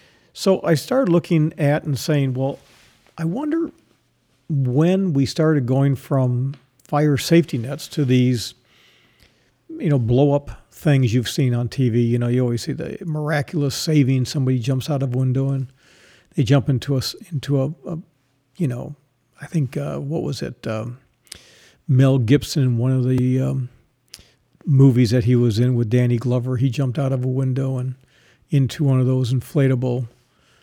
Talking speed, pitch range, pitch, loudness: 170 wpm, 125-145 Hz, 135 Hz, -20 LUFS